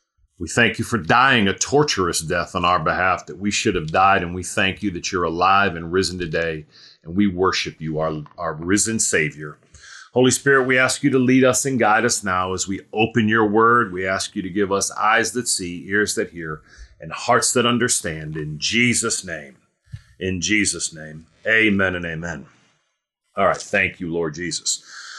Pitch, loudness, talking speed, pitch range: 95 Hz, -19 LUFS, 195 wpm, 85-115 Hz